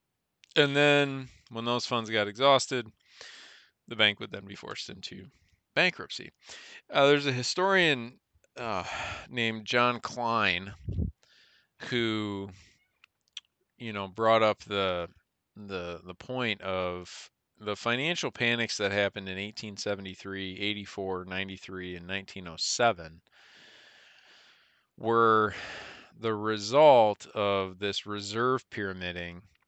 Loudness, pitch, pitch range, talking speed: -28 LUFS, 105 Hz, 95-120 Hz, 105 wpm